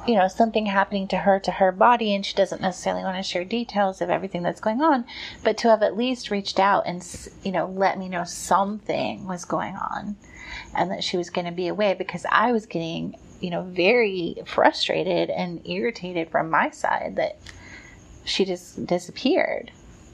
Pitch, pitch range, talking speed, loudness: 195 Hz, 180-220 Hz, 190 wpm, -24 LUFS